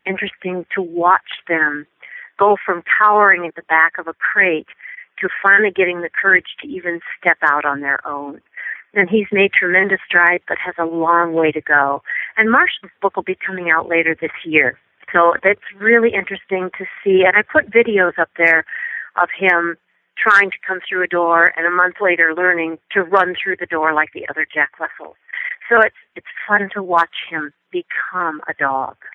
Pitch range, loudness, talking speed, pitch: 165-195 Hz, -16 LUFS, 190 wpm, 180 Hz